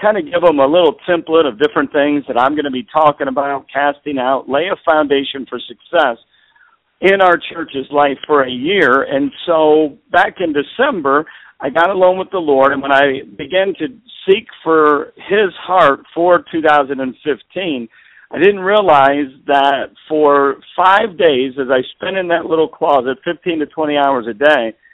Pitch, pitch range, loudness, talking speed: 150 Hz, 140-175 Hz, -14 LUFS, 175 wpm